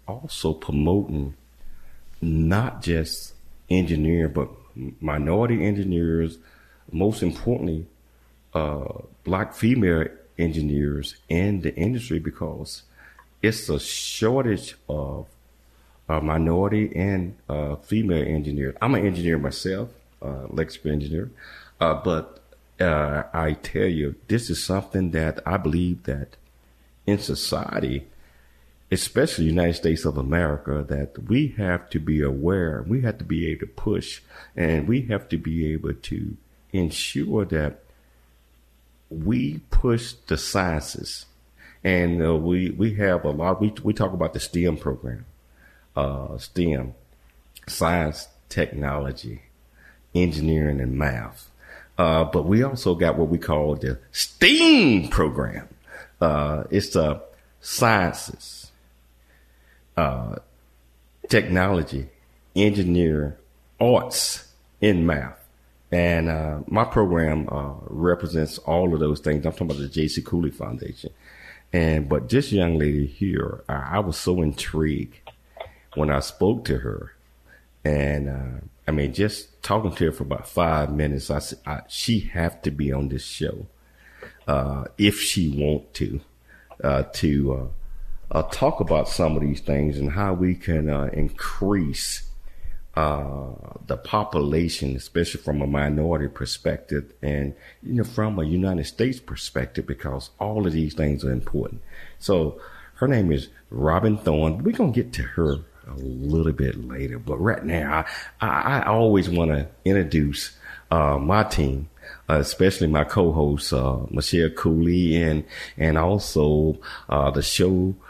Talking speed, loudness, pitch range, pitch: 135 wpm, -24 LUFS, 70-90 Hz, 80 Hz